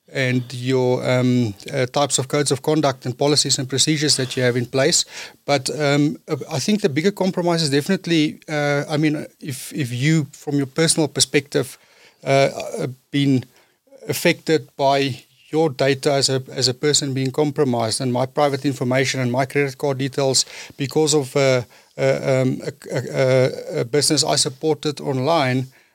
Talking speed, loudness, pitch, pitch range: 165 wpm, -20 LUFS, 140 Hz, 130-150 Hz